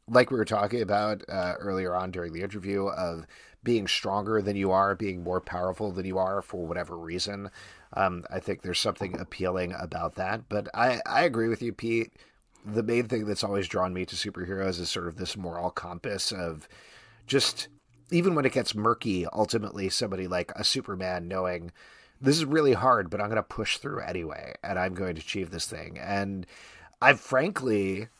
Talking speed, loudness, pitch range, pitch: 190 wpm, -29 LUFS, 90-110 Hz, 100 Hz